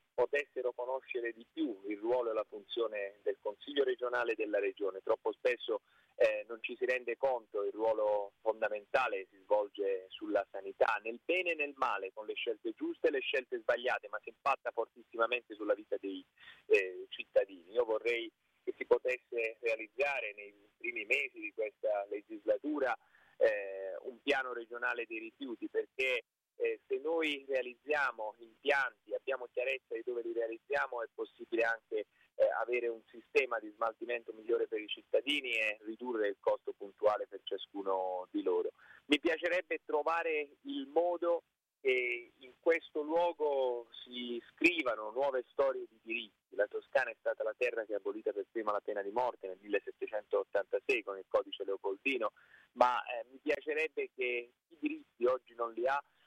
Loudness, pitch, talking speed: -36 LUFS, 390 Hz, 160 wpm